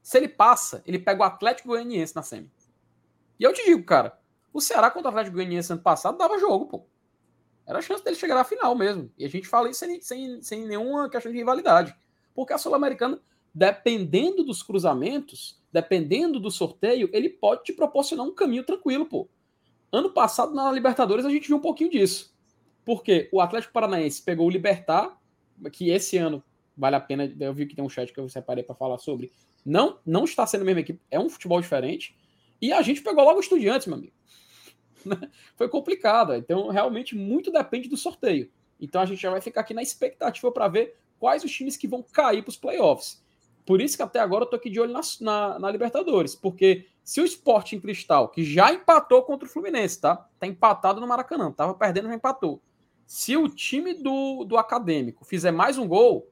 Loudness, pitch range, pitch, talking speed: -24 LUFS, 185-300 Hz, 235 Hz, 205 wpm